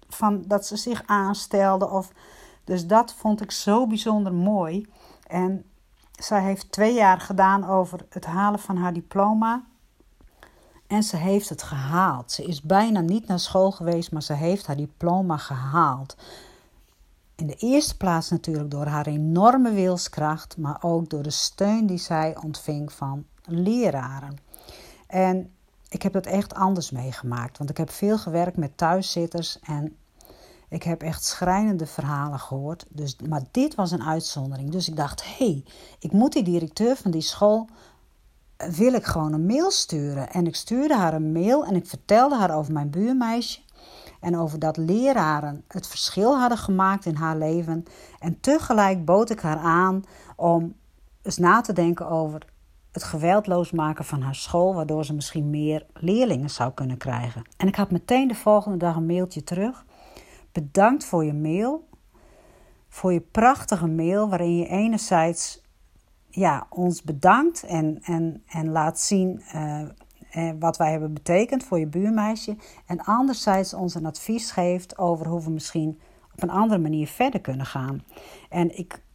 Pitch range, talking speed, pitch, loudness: 155-200 Hz, 160 wpm, 175 Hz, -24 LUFS